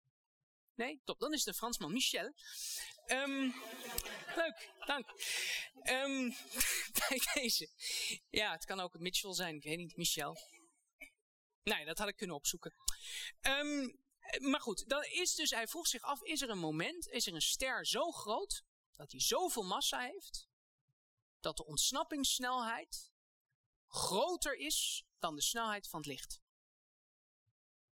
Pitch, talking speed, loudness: 250 Hz, 140 wpm, -38 LUFS